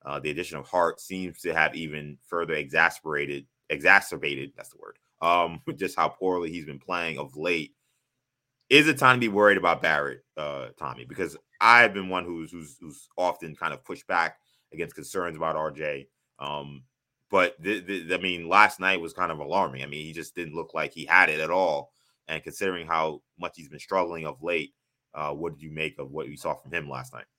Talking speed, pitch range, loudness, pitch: 205 wpm, 75-95 Hz, -25 LUFS, 85 Hz